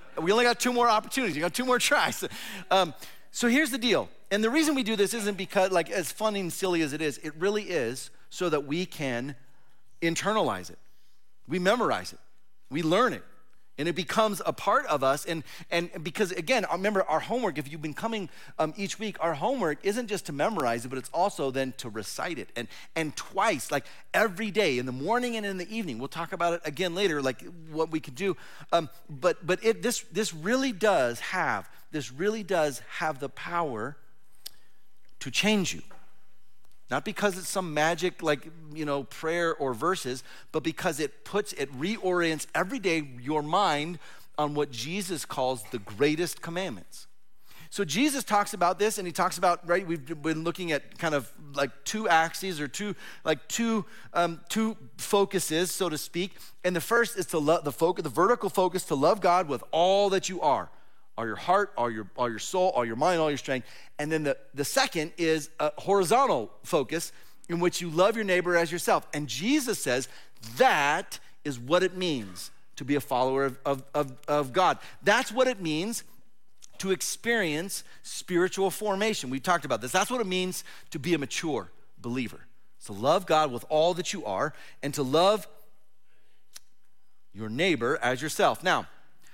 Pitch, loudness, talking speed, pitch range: 170 Hz, -28 LUFS, 190 wpm, 150-200 Hz